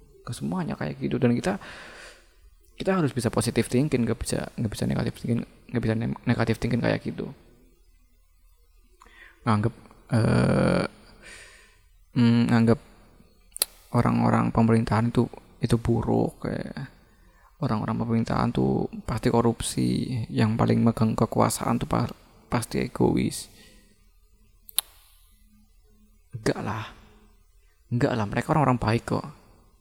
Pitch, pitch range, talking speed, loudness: 115 Hz, 85-120 Hz, 105 wpm, -26 LUFS